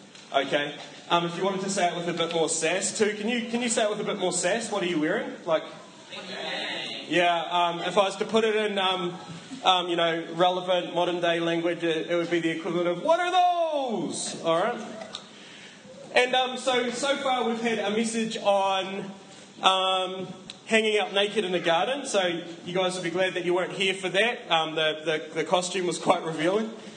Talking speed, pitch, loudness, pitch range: 215 wpm, 185 Hz, -26 LUFS, 175-215 Hz